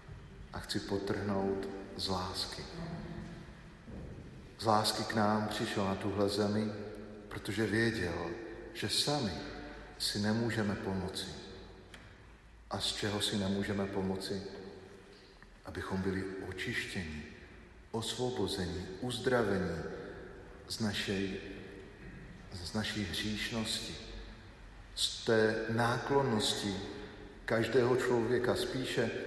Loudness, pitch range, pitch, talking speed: -35 LUFS, 95-110 Hz, 100 Hz, 85 wpm